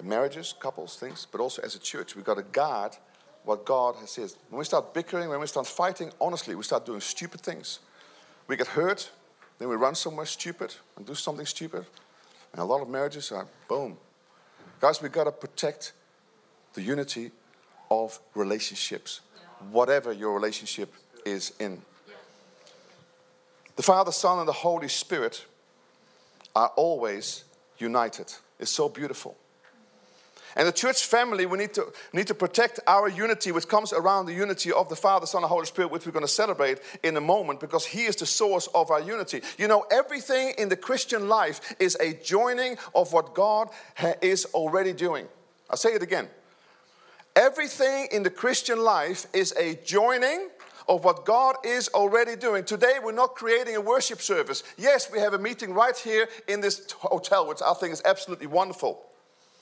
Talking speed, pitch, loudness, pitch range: 175 wpm, 195 Hz, -26 LUFS, 160-235 Hz